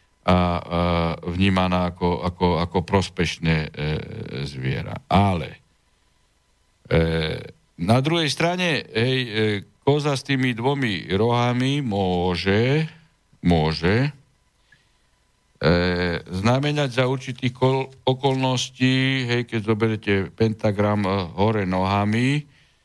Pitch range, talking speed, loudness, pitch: 90-130 Hz, 95 wpm, -22 LUFS, 110 Hz